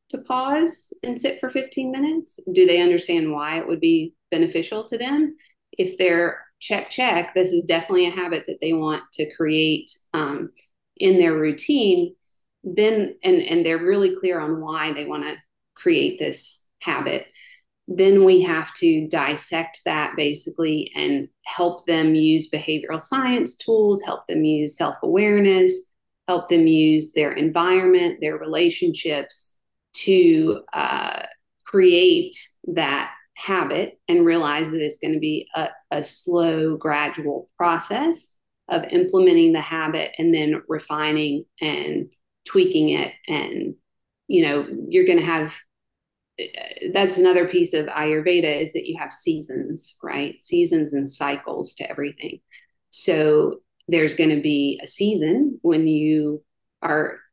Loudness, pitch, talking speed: -21 LUFS, 180 Hz, 140 wpm